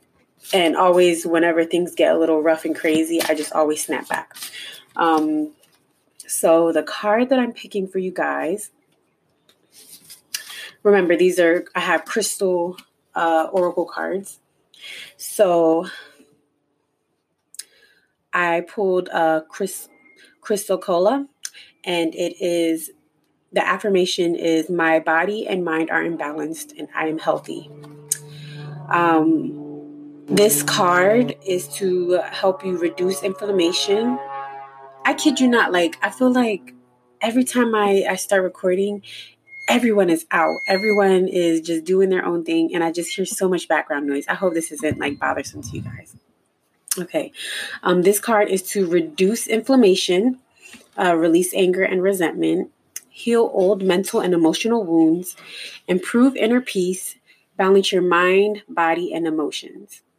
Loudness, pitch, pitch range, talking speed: -19 LUFS, 180 Hz, 165-200 Hz, 135 wpm